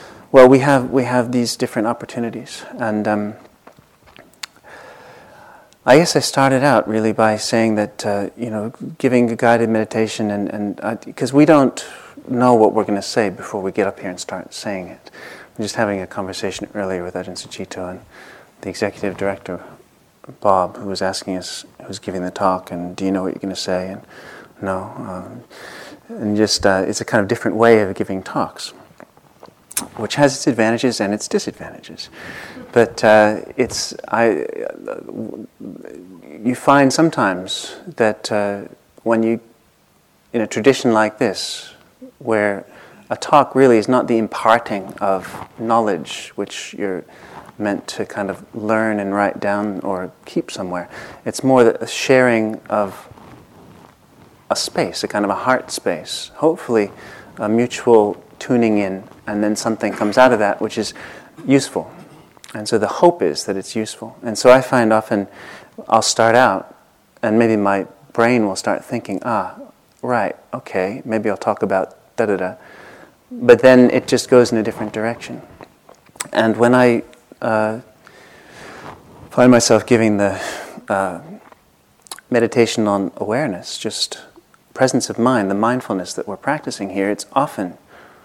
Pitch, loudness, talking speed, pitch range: 110 Hz, -17 LUFS, 160 wpm, 100-125 Hz